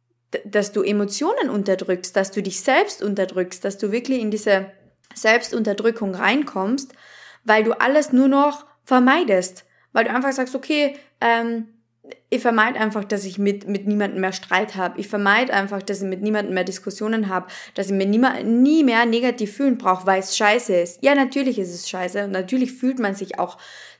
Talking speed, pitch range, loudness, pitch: 185 wpm, 195-255 Hz, -20 LUFS, 210 Hz